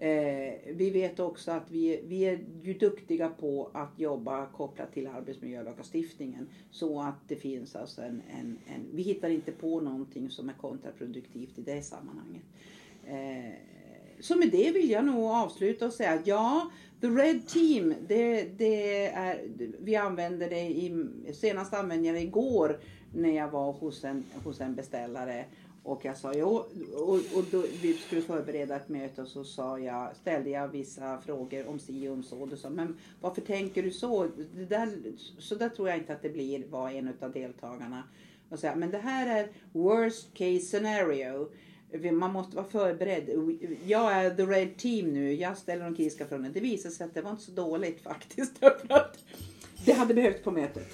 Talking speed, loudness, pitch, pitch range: 175 wpm, -31 LUFS, 175 Hz, 140-215 Hz